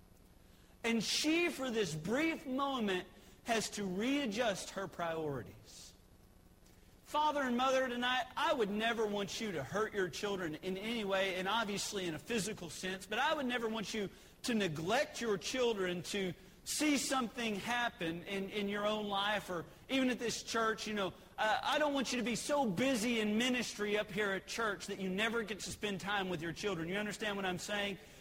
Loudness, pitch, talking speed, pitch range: -36 LUFS, 210 Hz, 190 wpm, 185-240 Hz